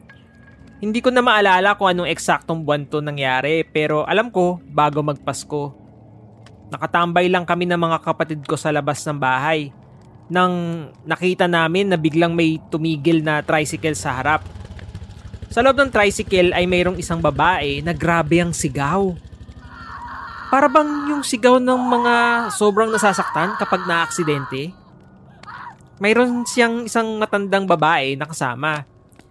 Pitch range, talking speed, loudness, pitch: 150-195 Hz, 135 wpm, -18 LUFS, 165 Hz